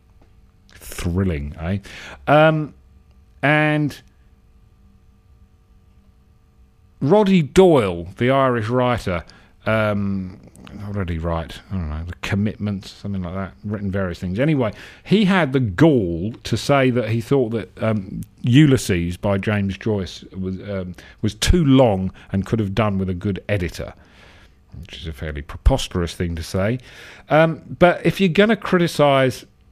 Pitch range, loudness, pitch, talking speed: 90-130 Hz, -20 LUFS, 100 Hz, 135 wpm